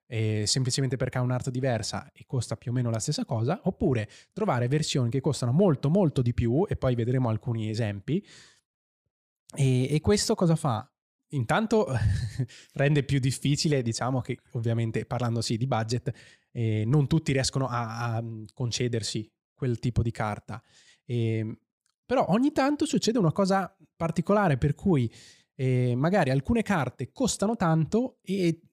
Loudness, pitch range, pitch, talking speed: -27 LUFS, 120-160 Hz, 130 Hz, 150 wpm